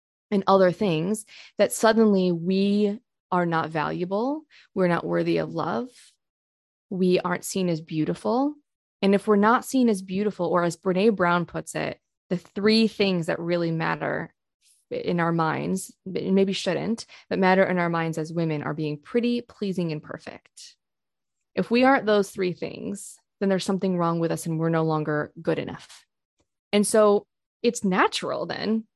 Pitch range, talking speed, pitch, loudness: 170-215 Hz, 165 wpm, 190 Hz, -24 LUFS